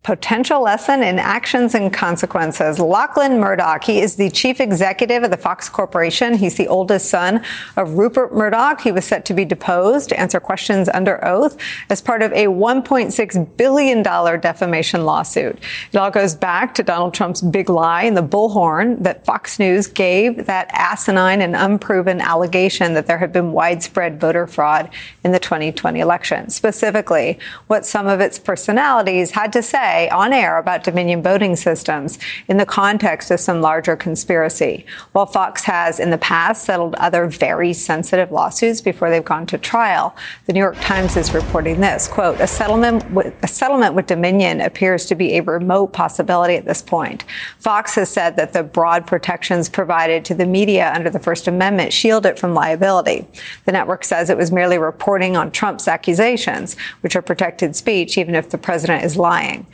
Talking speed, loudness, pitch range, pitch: 175 wpm, -16 LUFS, 175-210 Hz, 185 Hz